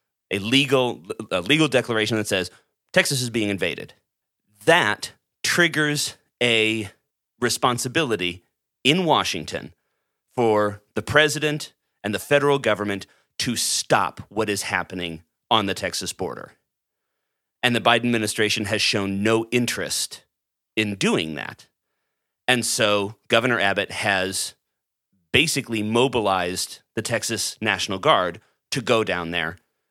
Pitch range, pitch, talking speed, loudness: 100-125 Hz, 110 Hz, 120 wpm, -22 LUFS